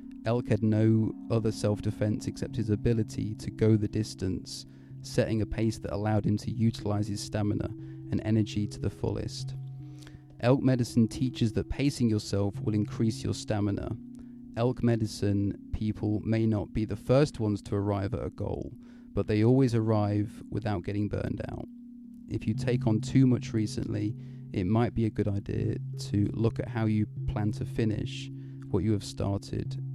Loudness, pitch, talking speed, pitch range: -30 LUFS, 110 Hz, 170 wpm, 105-130 Hz